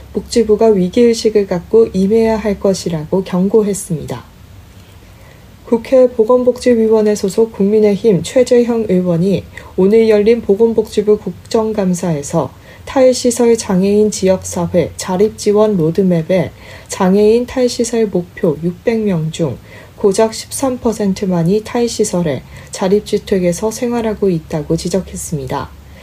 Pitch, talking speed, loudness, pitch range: 200 Hz, 265 characters per minute, -14 LUFS, 170-225 Hz